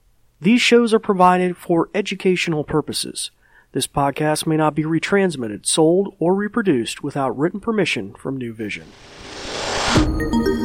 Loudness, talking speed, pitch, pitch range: -19 LUFS, 125 wpm, 155 Hz, 125-190 Hz